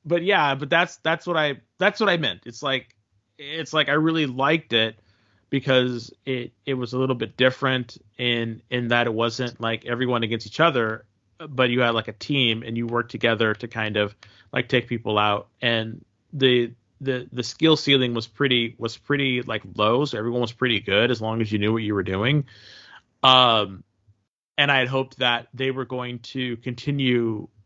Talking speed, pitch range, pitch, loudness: 195 wpm, 110-130 Hz, 120 Hz, -23 LUFS